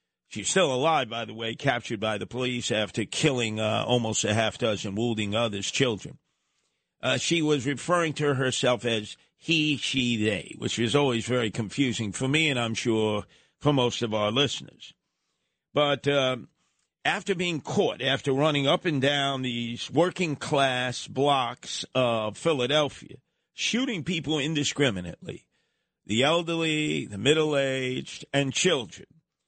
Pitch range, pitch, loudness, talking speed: 115-150 Hz, 130 Hz, -26 LUFS, 145 wpm